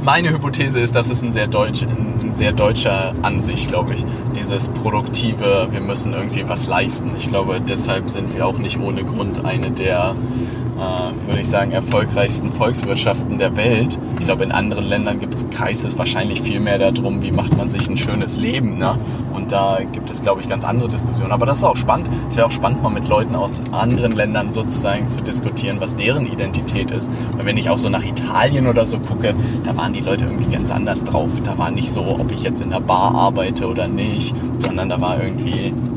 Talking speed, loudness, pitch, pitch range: 205 wpm, -18 LUFS, 120 Hz, 115-125 Hz